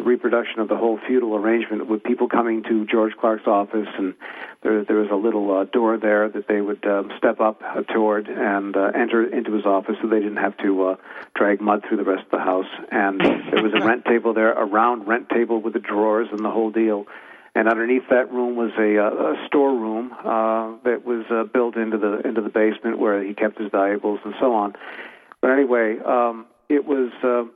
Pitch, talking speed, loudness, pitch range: 110 Hz, 220 wpm, -21 LUFS, 105-115 Hz